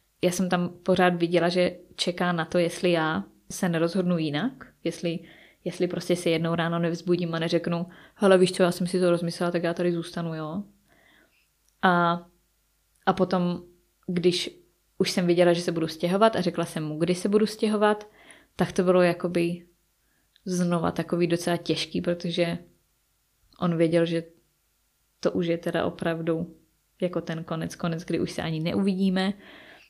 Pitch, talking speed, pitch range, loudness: 175 Hz, 165 wpm, 170-180 Hz, -26 LUFS